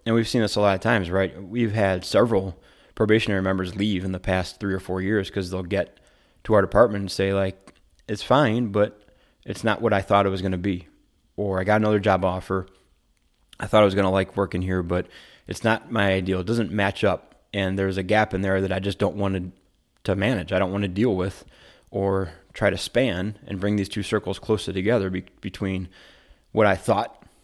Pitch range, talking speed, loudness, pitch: 95-105 Hz, 225 wpm, -23 LUFS, 100 Hz